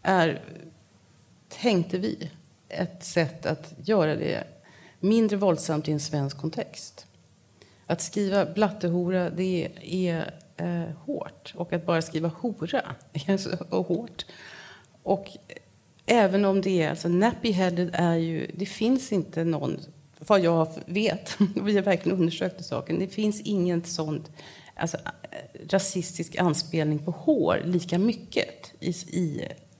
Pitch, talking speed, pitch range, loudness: 175 Hz, 125 wpm, 160-195 Hz, -27 LUFS